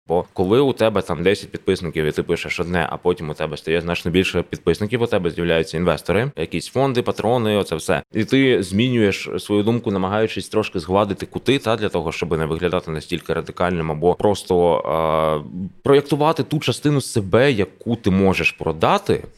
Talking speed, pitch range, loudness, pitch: 175 wpm, 85-110 Hz, -20 LUFS, 95 Hz